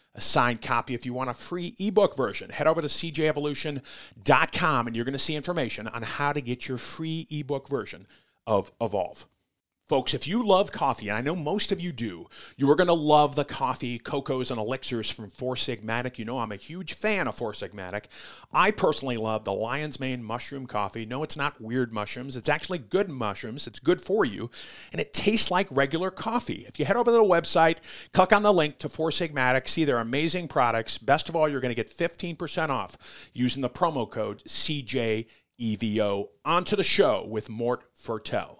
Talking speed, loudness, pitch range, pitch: 200 wpm, -27 LUFS, 120-165 Hz, 140 Hz